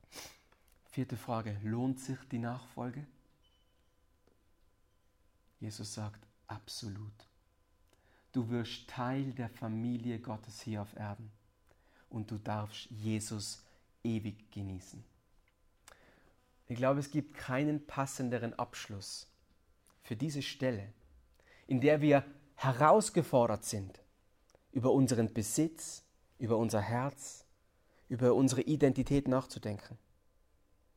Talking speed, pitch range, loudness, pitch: 95 wpm, 100-130 Hz, -35 LUFS, 115 Hz